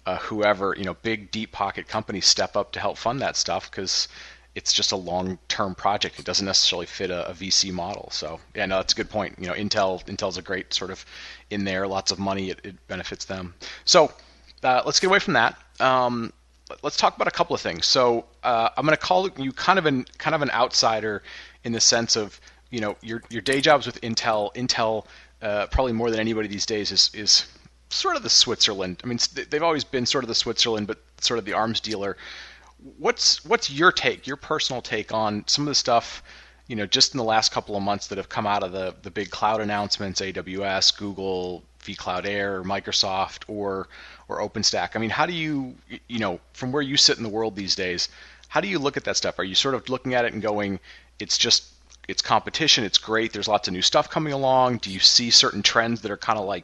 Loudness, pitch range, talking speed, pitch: -22 LUFS, 95-120 Hz, 230 wpm, 105 Hz